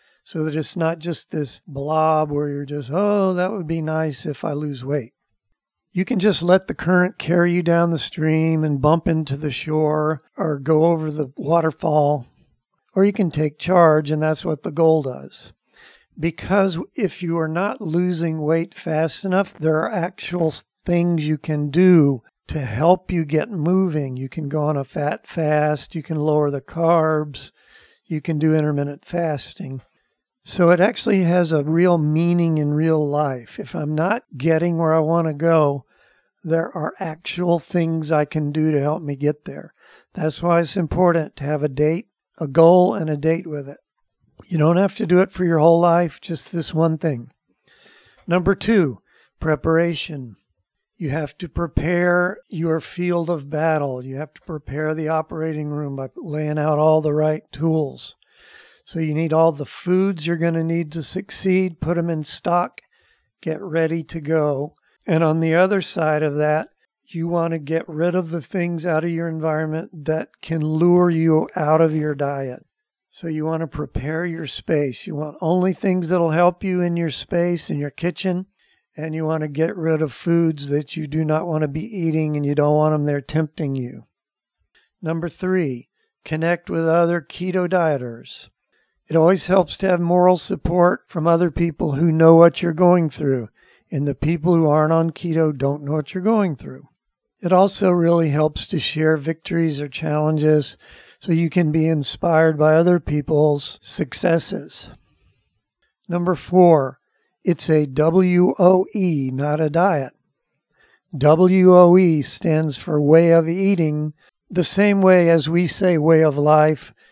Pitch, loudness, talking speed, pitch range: 160 Hz, -19 LUFS, 180 wpm, 150-175 Hz